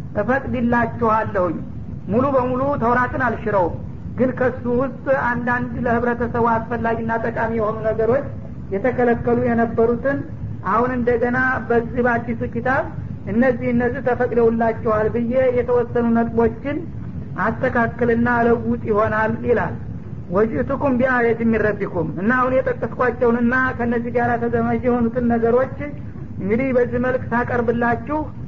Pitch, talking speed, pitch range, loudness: 235 Hz, 95 wpm, 230-250 Hz, -20 LUFS